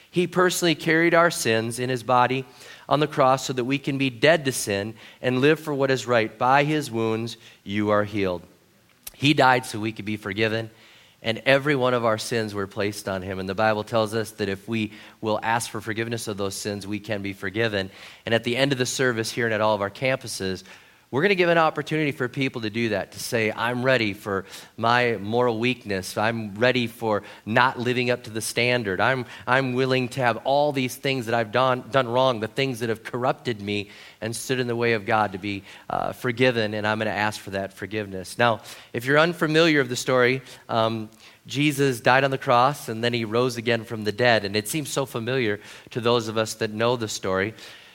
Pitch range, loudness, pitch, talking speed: 105-130 Hz, -23 LUFS, 115 Hz, 225 wpm